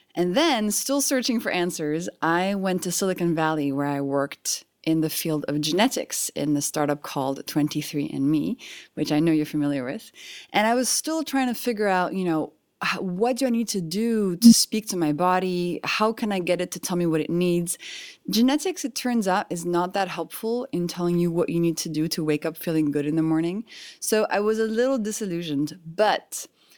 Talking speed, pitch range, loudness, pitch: 210 wpm, 160-230 Hz, -24 LUFS, 180 Hz